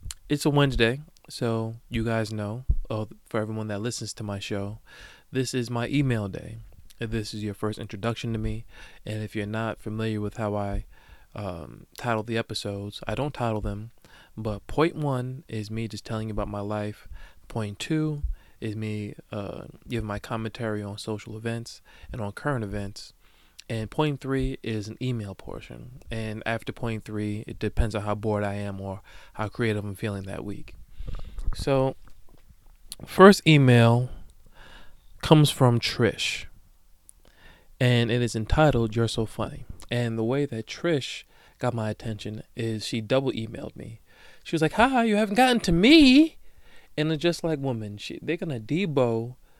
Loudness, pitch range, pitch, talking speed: -26 LUFS, 105-130 Hz, 110 Hz, 165 wpm